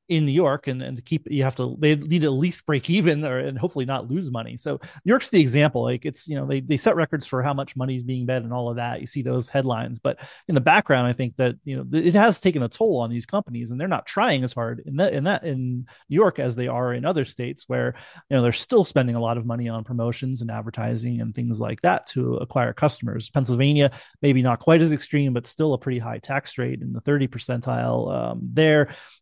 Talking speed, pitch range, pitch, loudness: 260 wpm, 120-150 Hz, 130 Hz, -23 LUFS